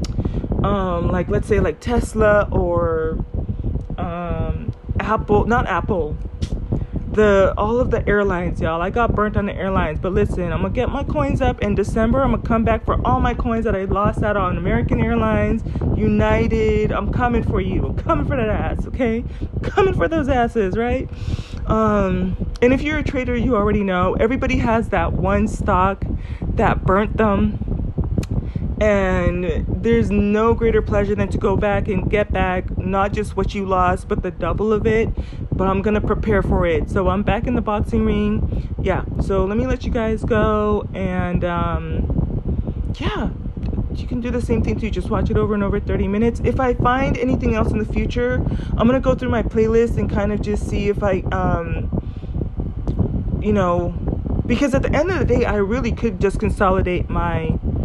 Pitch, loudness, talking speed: 185 Hz, -20 LUFS, 190 wpm